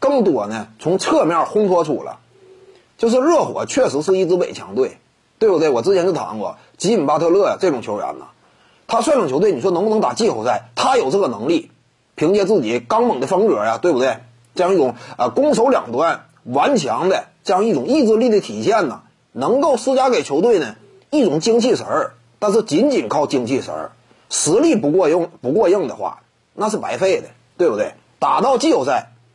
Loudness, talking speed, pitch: -17 LUFS, 295 characters per minute, 230 Hz